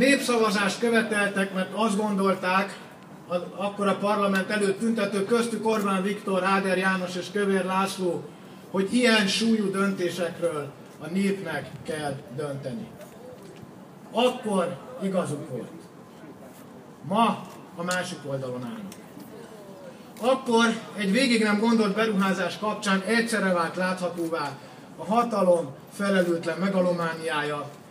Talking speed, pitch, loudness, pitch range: 105 wpm, 195 Hz, -25 LUFS, 180-215 Hz